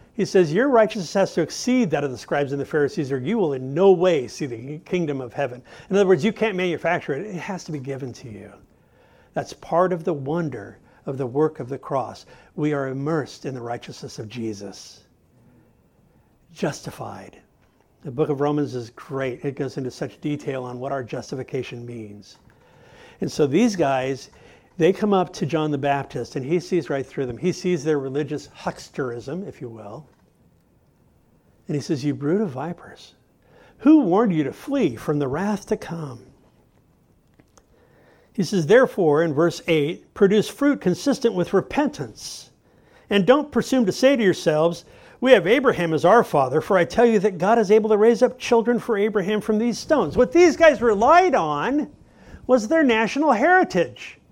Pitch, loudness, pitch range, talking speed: 165 Hz, -21 LUFS, 140-215 Hz, 185 wpm